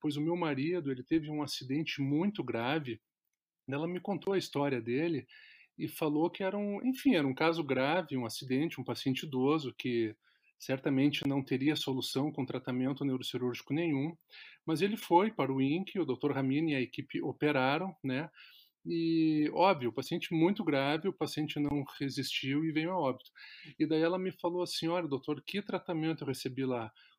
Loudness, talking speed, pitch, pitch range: -33 LUFS, 175 wpm, 150 Hz, 135-165 Hz